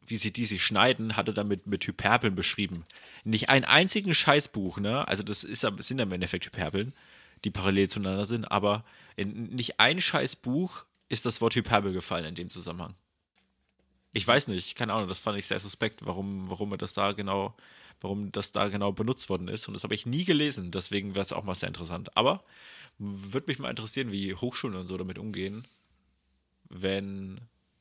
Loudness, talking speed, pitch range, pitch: -28 LUFS, 190 wpm, 95-115 Hz, 100 Hz